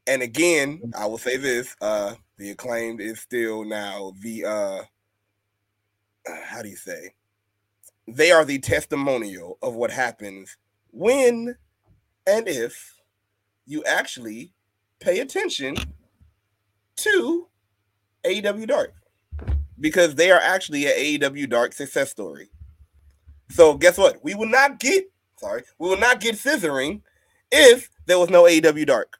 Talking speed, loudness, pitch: 130 wpm, -20 LUFS, 125 Hz